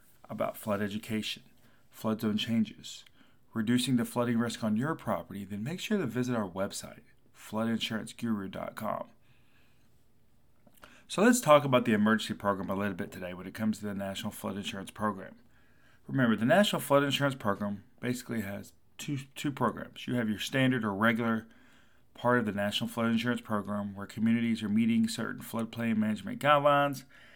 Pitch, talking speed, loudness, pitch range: 115 Hz, 160 wpm, -31 LUFS, 105-125 Hz